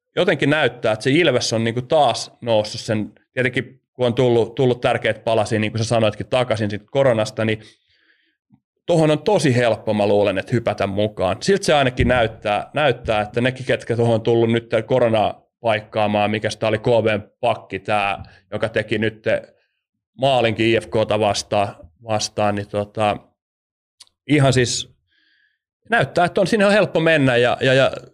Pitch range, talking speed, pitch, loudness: 110-130 Hz, 155 wpm, 115 Hz, -19 LUFS